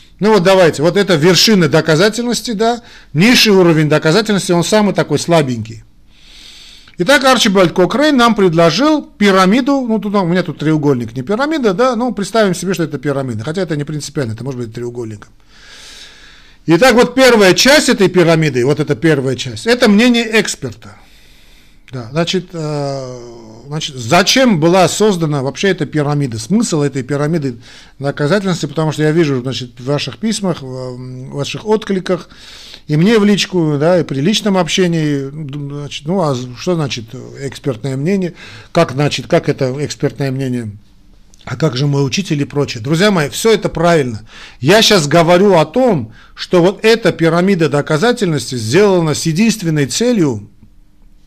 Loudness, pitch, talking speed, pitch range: -13 LUFS, 160 Hz, 150 wpm, 135-195 Hz